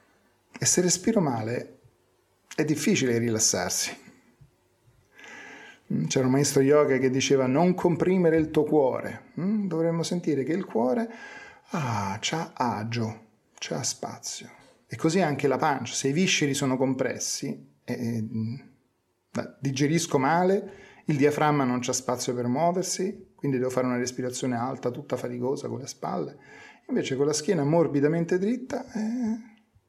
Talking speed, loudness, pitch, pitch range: 135 wpm, -26 LUFS, 145 Hz, 125-180 Hz